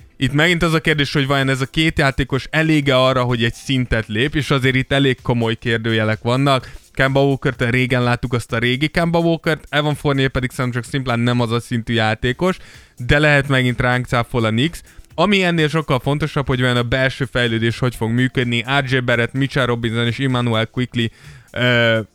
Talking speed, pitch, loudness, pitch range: 195 wpm, 130 Hz, -17 LUFS, 120-140 Hz